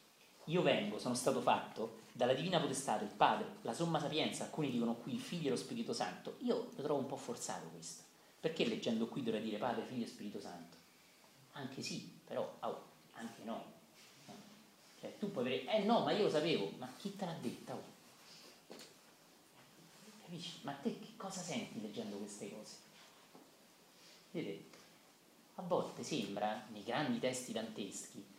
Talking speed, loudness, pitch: 165 wpm, -40 LUFS, 155 Hz